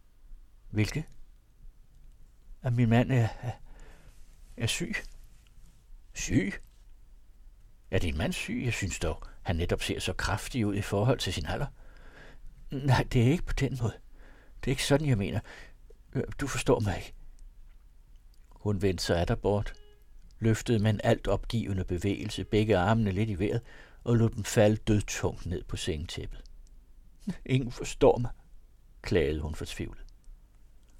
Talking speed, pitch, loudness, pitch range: 145 wpm, 105 Hz, -30 LUFS, 95-120 Hz